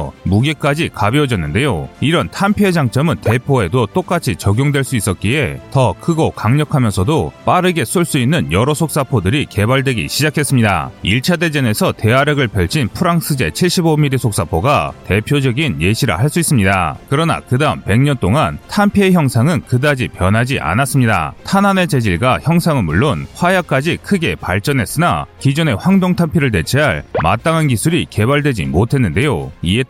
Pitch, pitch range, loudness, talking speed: 135 Hz, 110-160 Hz, -14 LUFS, 355 characters per minute